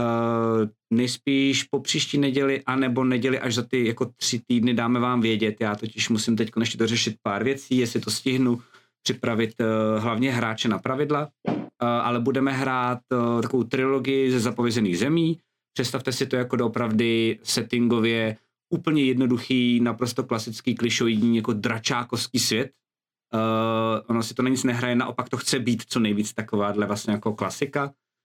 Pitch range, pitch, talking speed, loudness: 115-130 Hz, 120 Hz, 155 wpm, -24 LUFS